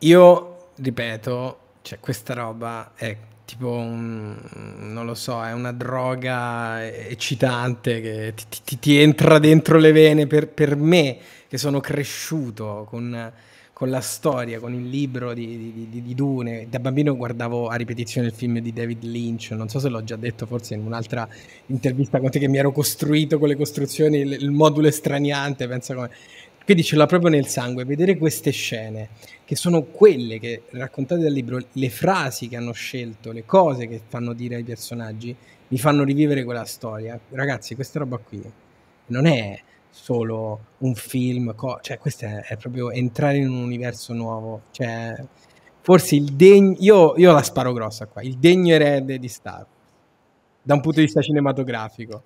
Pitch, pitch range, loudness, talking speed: 125 Hz, 115-145 Hz, -20 LUFS, 170 wpm